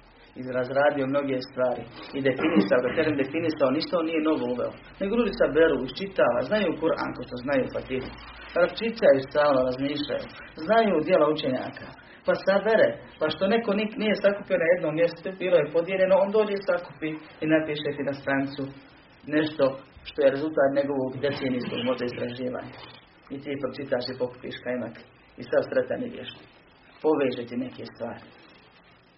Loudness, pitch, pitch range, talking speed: -26 LUFS, 145 Hz, 130-180 Hz, 150 wpm